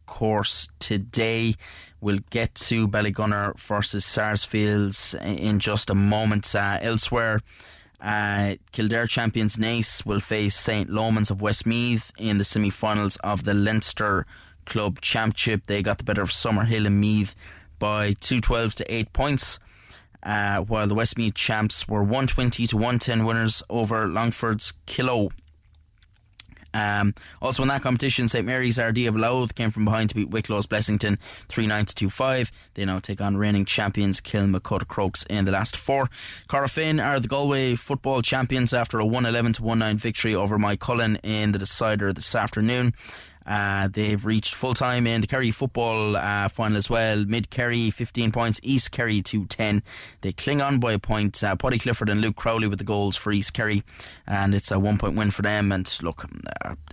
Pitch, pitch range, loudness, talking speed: 105 Hz, 100-115 Hz, -24 LUFS, 170 wpm